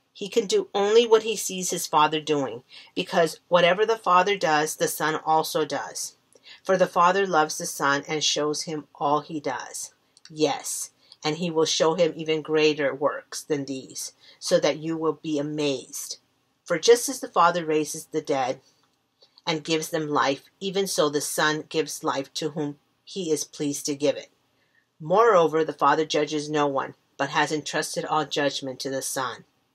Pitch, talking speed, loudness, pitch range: 155 Hz, 175 wpm, -24 LUFS, 150-175 Hz